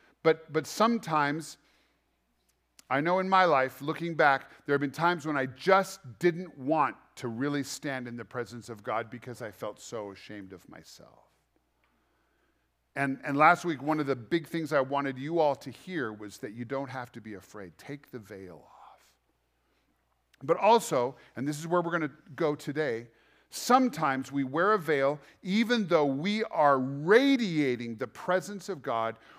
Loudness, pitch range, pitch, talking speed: -29 LUFS, 120-165 Hz, 140 Hz, 175 wpm